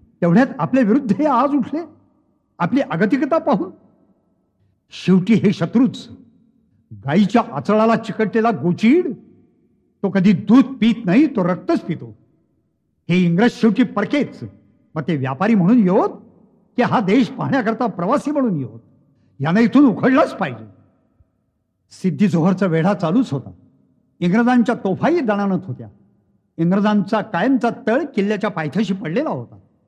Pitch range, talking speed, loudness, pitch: 170-240 Hz, 125 wpm, -18 LUFS, 210 Hz